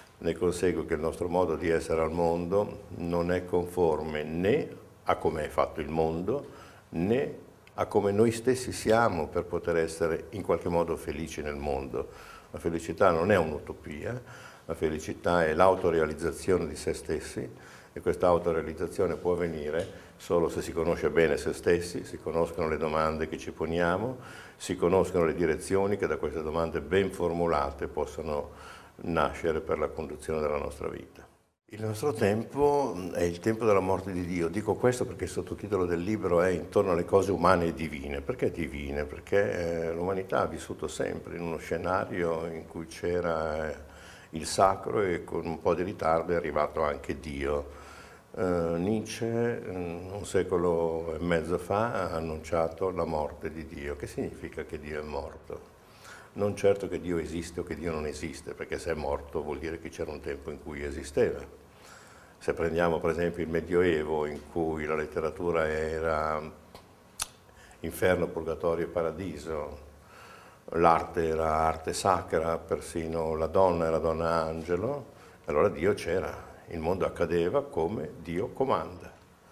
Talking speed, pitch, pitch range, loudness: 160 wpm, 85 Hz, 80-95 Hz, -30 LUFS